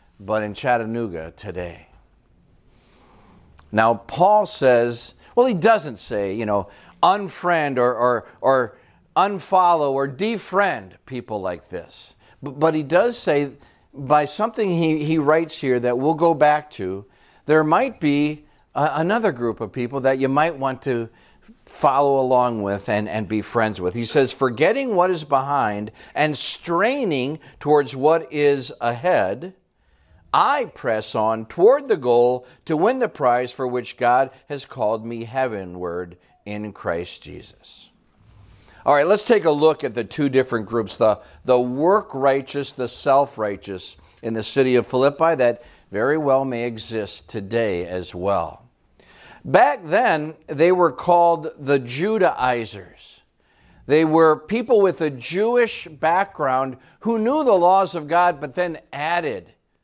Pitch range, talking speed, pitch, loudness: 110-160 Hz, 145 wpm, 135 Hz, -20 LUFS